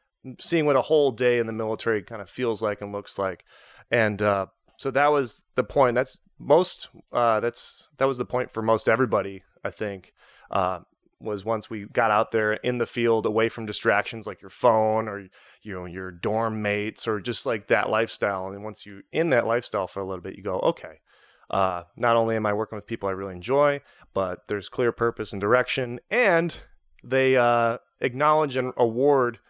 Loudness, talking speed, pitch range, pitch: -25 LUFS, 200 wpm, 100-125 Hz, 110 Hz